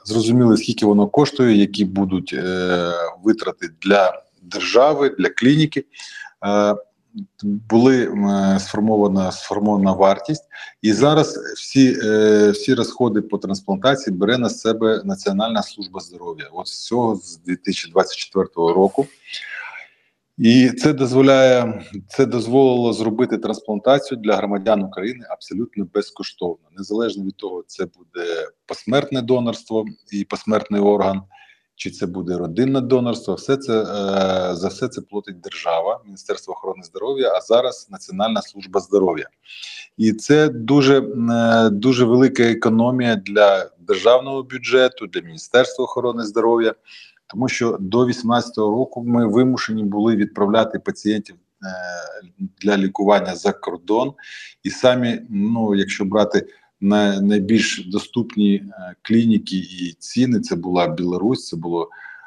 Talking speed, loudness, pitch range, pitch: 120 wpm, -18 LUFS, 100-130 Hz, 110 Hz